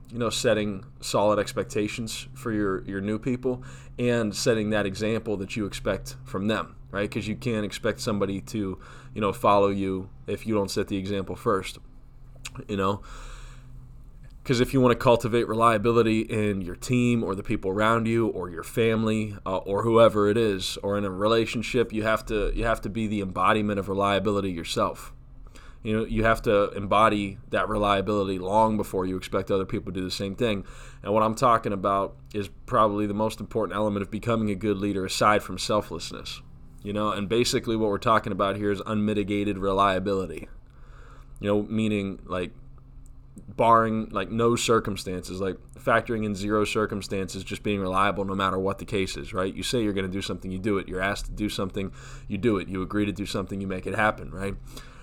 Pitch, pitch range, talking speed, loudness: 105 Hz, 95-115 Hz, 195 wpm, -26 LUFS